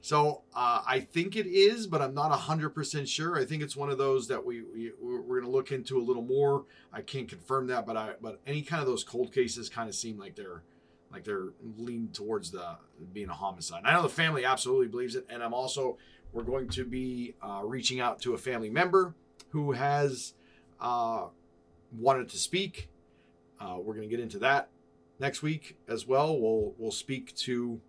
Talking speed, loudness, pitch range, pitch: 210 wpm, -31 LUFS, 110-155 Hz, 130 Hz